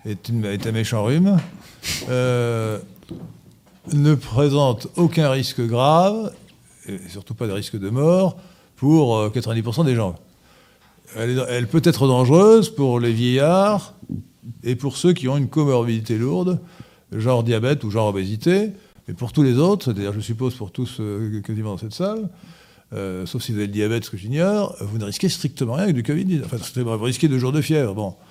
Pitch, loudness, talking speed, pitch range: 125 Hz, -20 LUFS, 180 wpm, 110-160 Hz